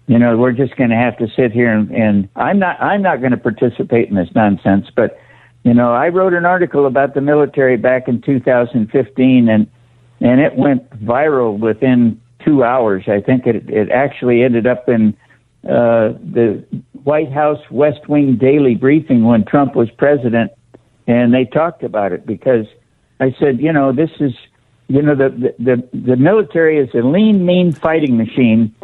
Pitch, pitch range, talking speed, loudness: 125 Hz, 120-145 Hz, 185 wpm, -13 LUFS